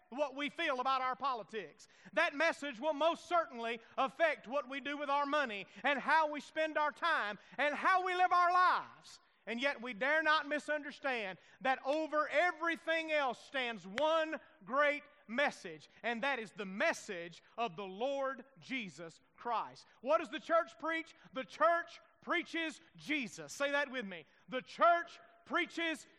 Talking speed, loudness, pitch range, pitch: 165 wpm, -35 LUFS, 255-325 Hz, 290 Hz